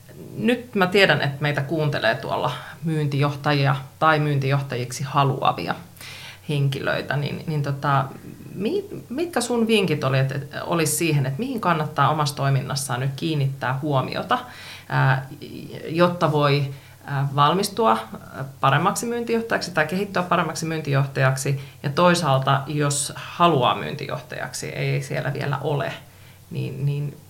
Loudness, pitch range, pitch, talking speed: -22 LUFS, 135-165 Hz, 145 Hz, 110 wpm